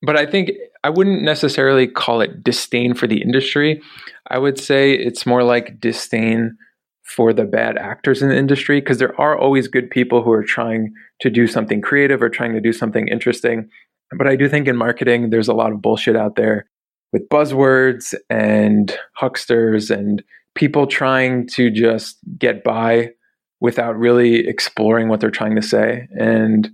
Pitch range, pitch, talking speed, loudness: 115-135 Hz, 120 Hz, 175 wpm, -16 LUFS